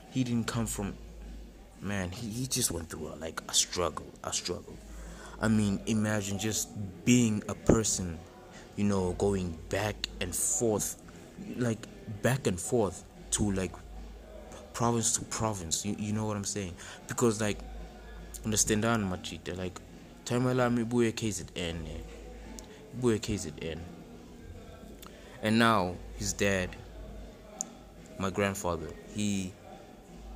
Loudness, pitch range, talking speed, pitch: -31 LUFS, 90-115 Hz, 125 wpm, 100 Hz